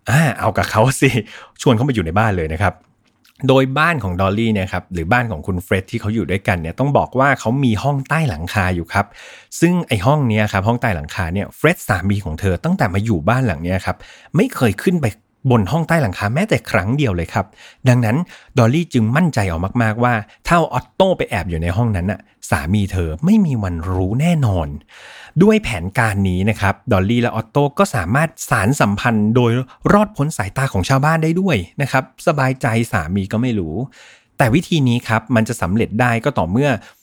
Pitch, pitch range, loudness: 115 Hz, 100-135 Hz, -17 LUFS